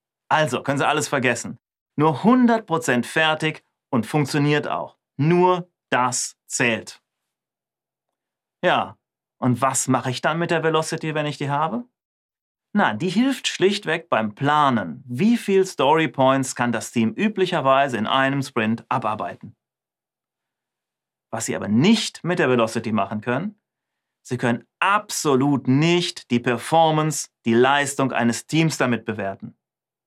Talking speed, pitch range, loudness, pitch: 130 wpm, 125-165 Hz, -21 LUFS, 145 Hz